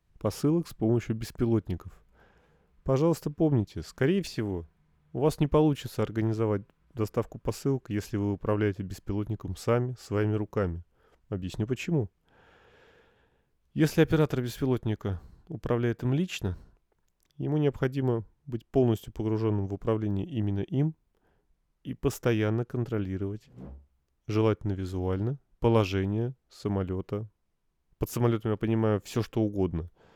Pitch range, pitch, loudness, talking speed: 100-125 Hz, 110 Hz, -29 LUFS, 105 wpm